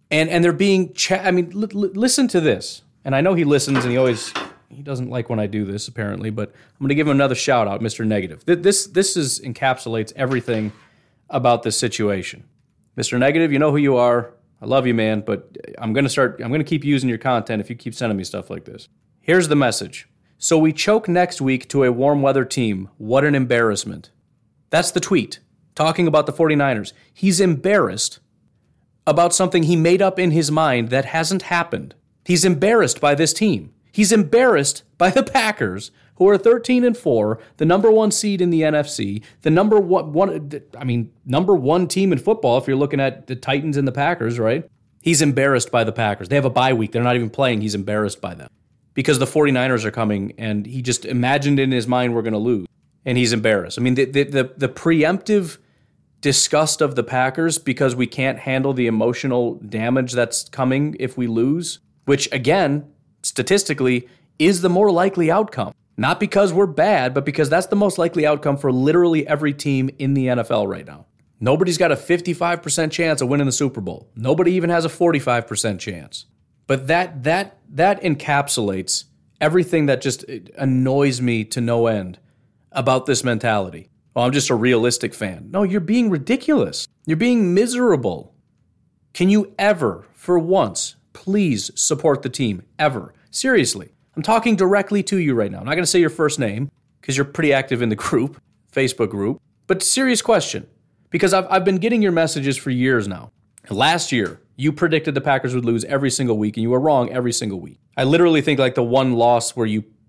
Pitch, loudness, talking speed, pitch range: 140 Hz, -19 LUFS, 200 wpm, 120-170 Hz